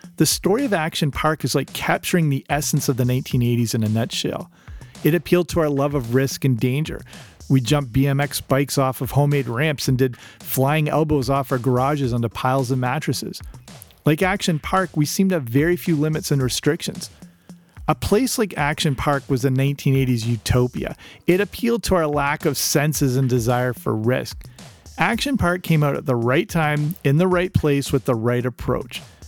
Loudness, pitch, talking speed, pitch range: -20 LUFS, 145 Hz, 190 wpm, 130-160 Hz